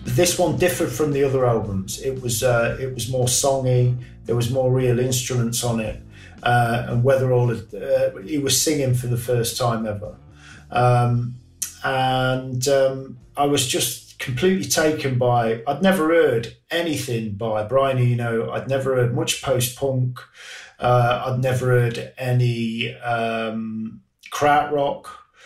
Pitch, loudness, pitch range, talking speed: 125 Hz, -21 LUFS, 115-135 Hz, 150 wpm